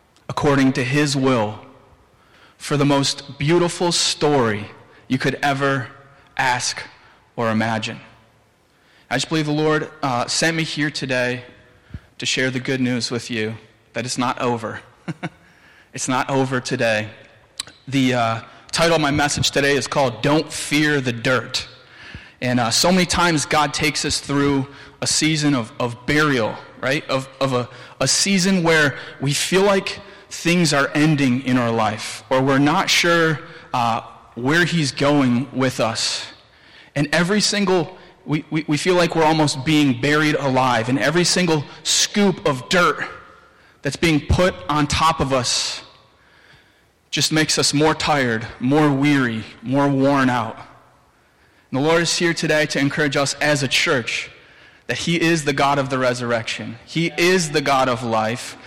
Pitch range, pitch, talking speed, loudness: 125-155 Hz, 140 Hz, 160 wpm, -19 LUFS